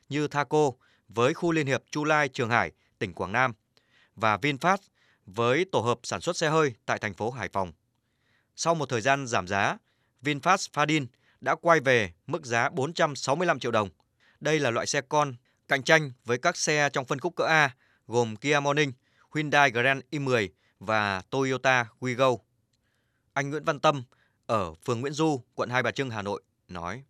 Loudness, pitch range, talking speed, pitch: -27 LUFS, 115-150 Hz, 180 wpm, 130 Hz